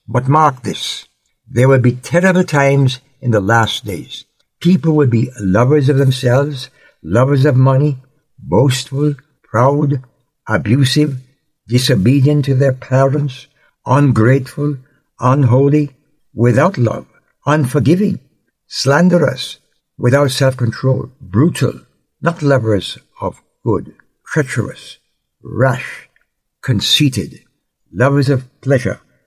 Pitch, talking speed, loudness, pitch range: 135 Hz, 95 wpm, -14 LUFS, 125-145 Hz